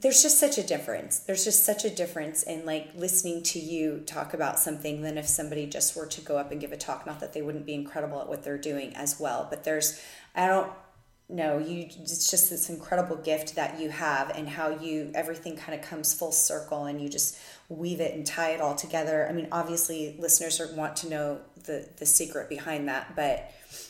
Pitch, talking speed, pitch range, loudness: 155 Hz, 220 wpm, 150-170 Hz, -27 LUFS